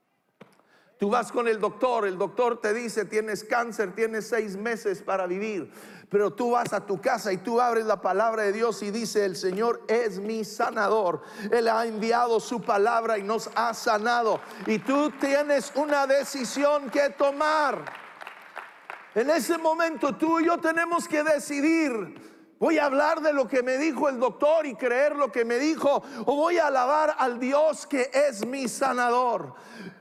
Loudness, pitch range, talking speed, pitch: -25 LUFS, 220-285 Hz, 175 wpm, 245 Hz